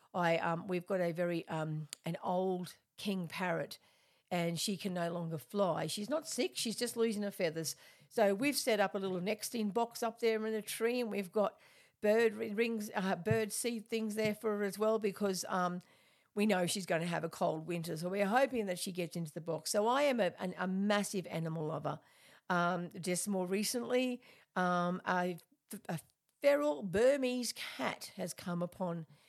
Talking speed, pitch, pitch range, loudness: 195 wpm, 195 Hz, 175-220 Hz, -36 LUFS